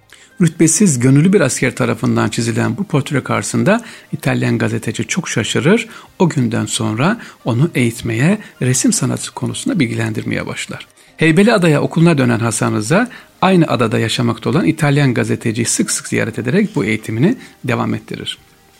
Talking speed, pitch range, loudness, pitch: 135 wpm, 115-170 Hz, -15 LUFS, 130 Hz